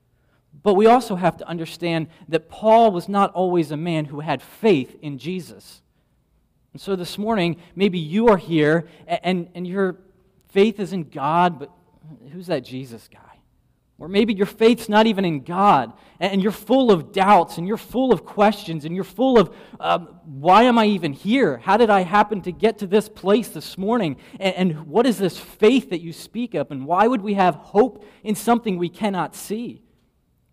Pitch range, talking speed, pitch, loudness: 165-215 Hz, 190 wpm, 190 Hz, -20 LUFS